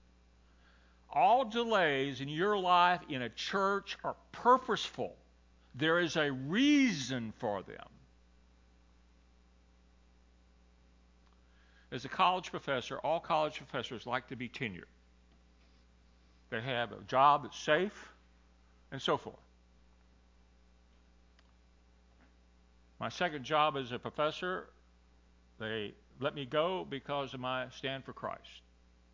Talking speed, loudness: 105 wpm, -33 LUFS